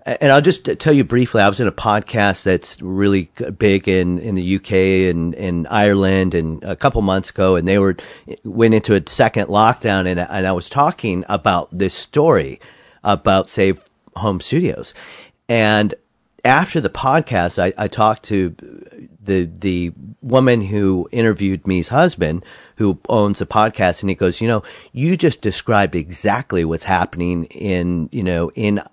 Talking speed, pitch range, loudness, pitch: 165 wpm, 90-110 Hz, -17 LUFS, 100 Hz